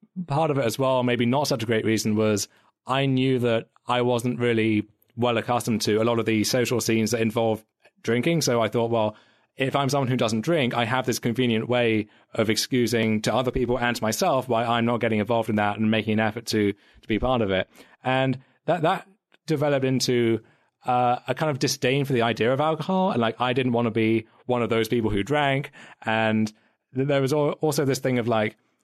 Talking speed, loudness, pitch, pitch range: 220 wpm, -24 LUFS, 120 Hz, 110-130 Hz